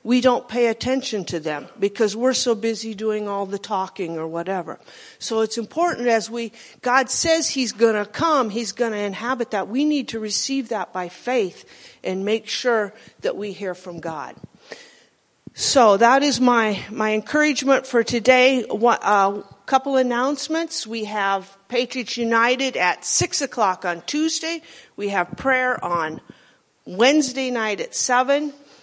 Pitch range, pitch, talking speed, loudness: 210-265 Hz, 235 Hz, 150 wpm, -21 LUFS